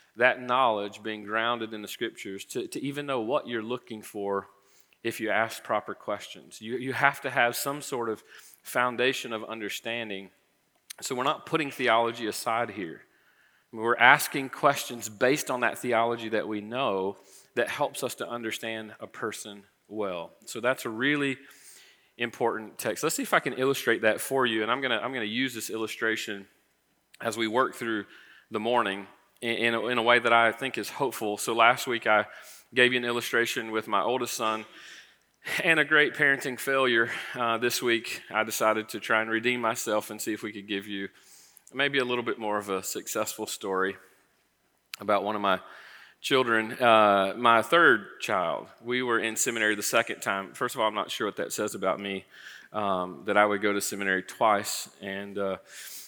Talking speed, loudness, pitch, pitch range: 190 wpm, -27 LUFS, 110 Hz, 105-120 Hz